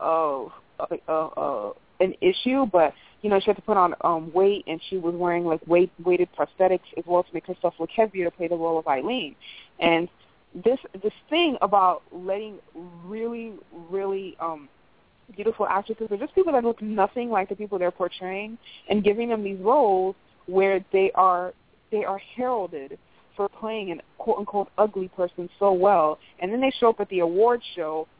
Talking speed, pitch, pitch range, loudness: 185 wpm, 190 Hz, 175-215 Hz, -24 LUFS